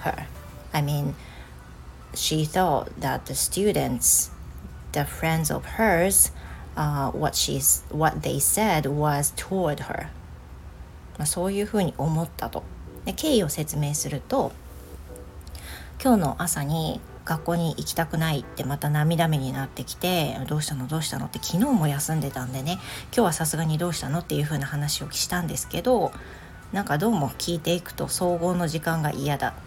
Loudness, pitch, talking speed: -25 LUFS, 150 Hz, 285 characters per minute